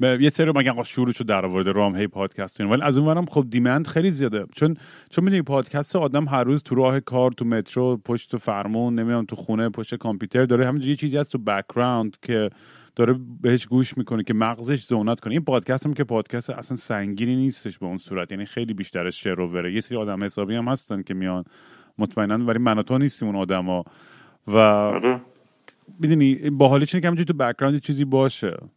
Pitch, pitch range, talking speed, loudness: 120 Hz, 105-135 Hz, 200 wpm, -22 LUFS